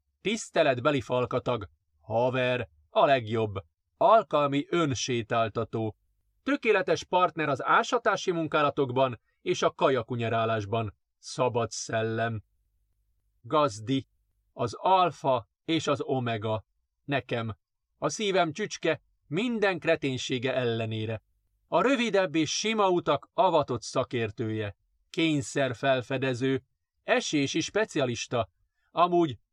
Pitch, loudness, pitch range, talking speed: 130 Hz, -28 LUFS, 110-160 Hz, 85 wpm